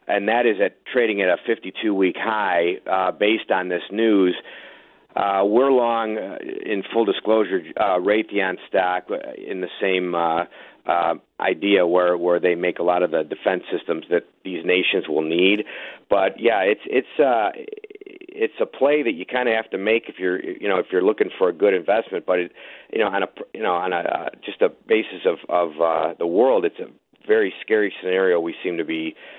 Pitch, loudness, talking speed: 110 Hz, -21 LUFS, 200 wpm